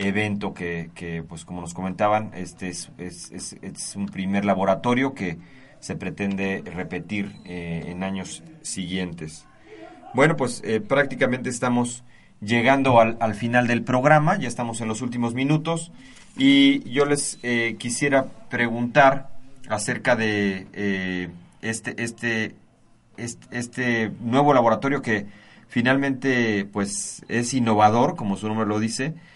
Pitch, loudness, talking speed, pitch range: 115 Hz, -23 LUFS, 135 wpm, 100-125 Hz